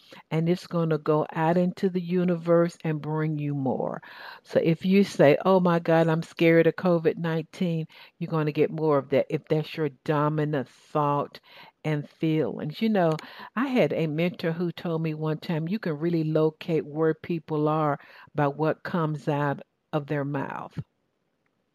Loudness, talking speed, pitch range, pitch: -26 LUFS, 175 wpm, 150-170 Hz, 160 Hz